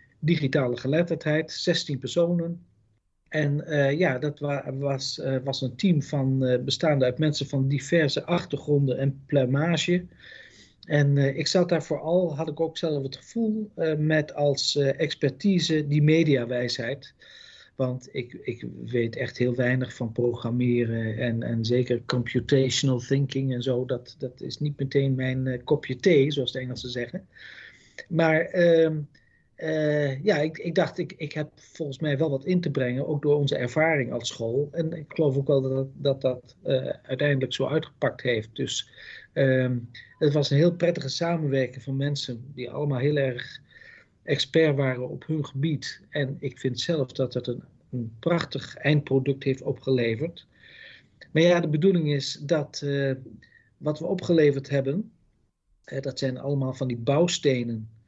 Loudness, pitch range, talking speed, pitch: -26 LUFS, 130-155 Hz, 160 wpm, 140 Hz